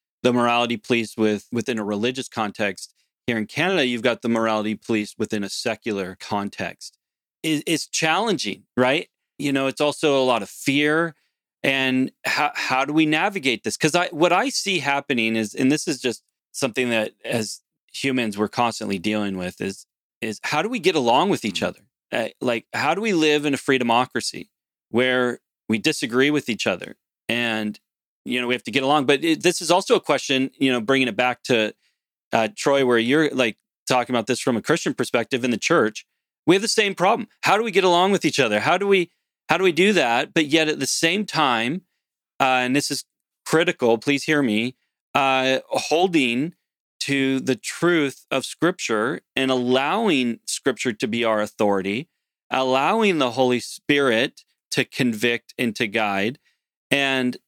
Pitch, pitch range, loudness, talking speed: 130 Hz, 115-155 Hz, -21 LUFS, 185 wpm